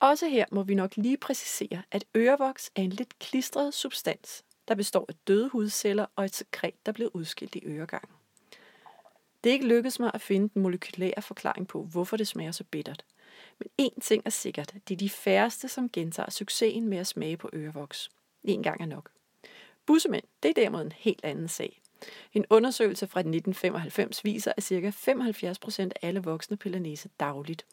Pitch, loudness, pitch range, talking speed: 205 Hz, -30 LUFS, 185-230 Hz, 185 wpm